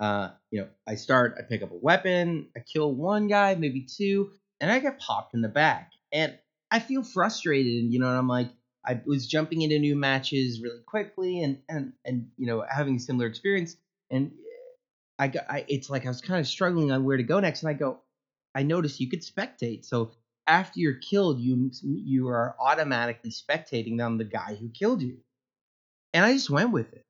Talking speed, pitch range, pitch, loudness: 210 wpm, 125-180 Hz, 140 Hz, -27 LUFS